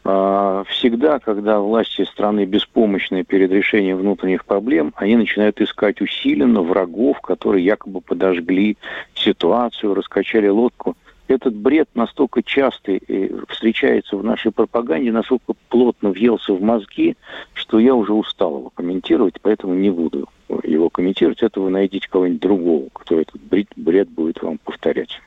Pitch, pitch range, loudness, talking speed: 105 Hz, 95-115 Hz, -18 LUFS, 130 wpm